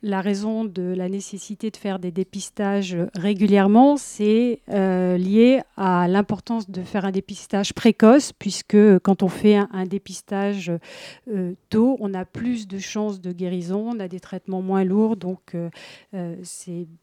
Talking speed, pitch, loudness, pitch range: 160 wpm, 195 Hz, -21 LUFS, 185-210 Hz